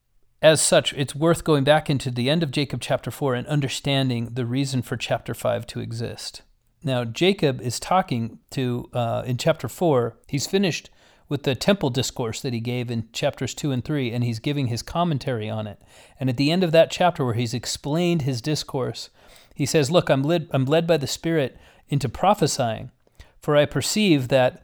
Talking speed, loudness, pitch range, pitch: 195 wpm, -23 LUFS, 125-155 Hz, 135 Hz